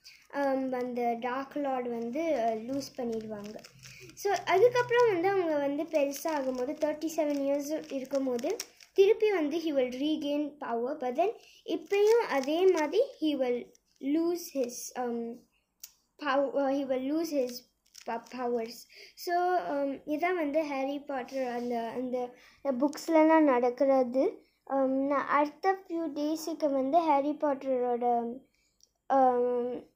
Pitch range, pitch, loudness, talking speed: 250-320 Hz, 280 Hz, -30 LUFS, 105 wpm